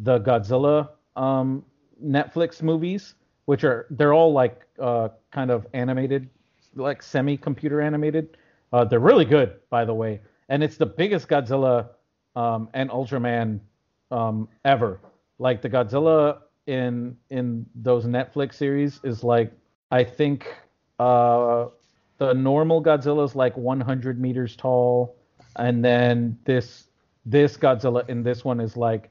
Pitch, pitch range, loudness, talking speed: 130 Hz, 120-145 Hz, -22 LUFS, 140 wpm